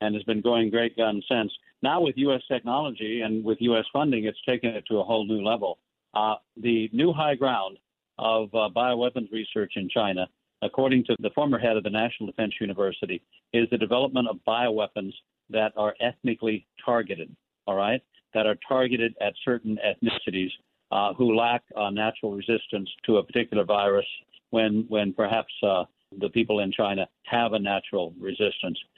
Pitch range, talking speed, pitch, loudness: 105-120 Hz, 170 wpm, 110 Hz, -26 LUFS